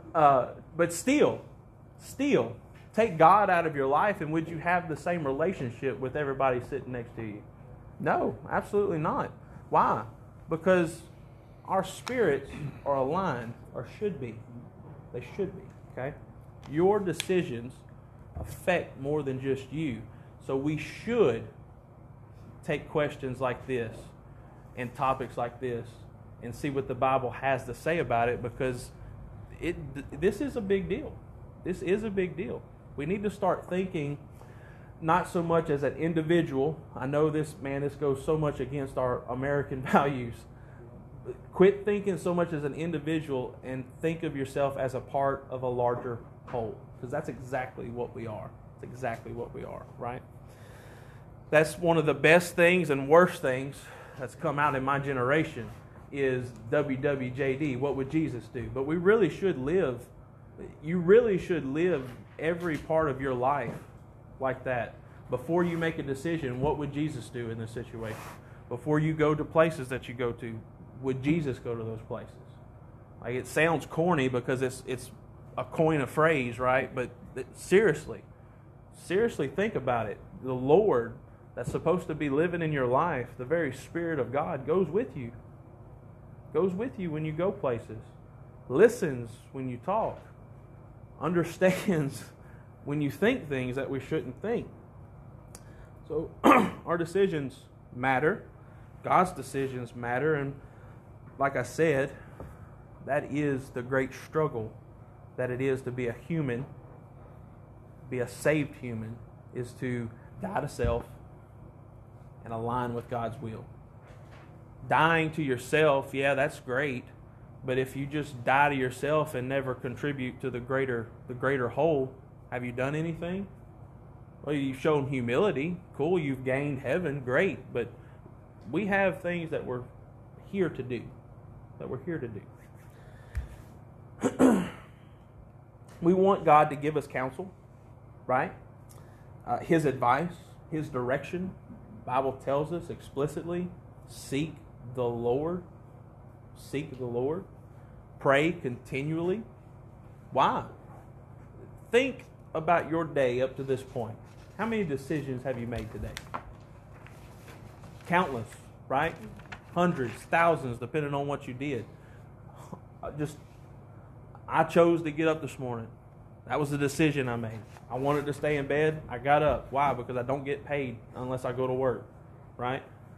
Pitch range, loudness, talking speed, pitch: 120-150 Hz, -29 LUFS, 145 wpm, 130 Hz